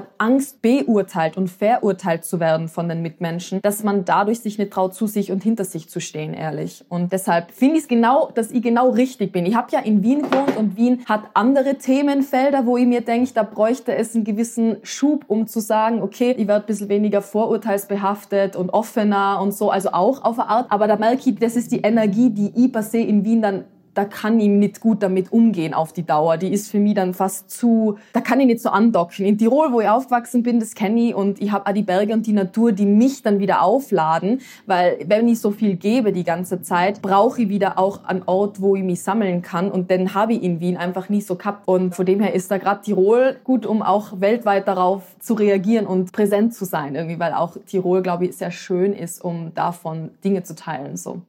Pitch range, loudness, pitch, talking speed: 185-230 Hz, -19 LUFS, 205 Hz, 235 wpm